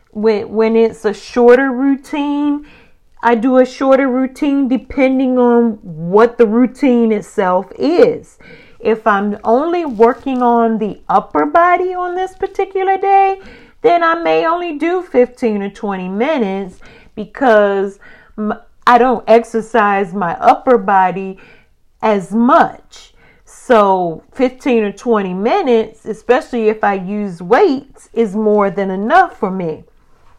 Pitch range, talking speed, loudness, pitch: 210-270 Hz, 125 wpm, -14 LUFS, 230 Hz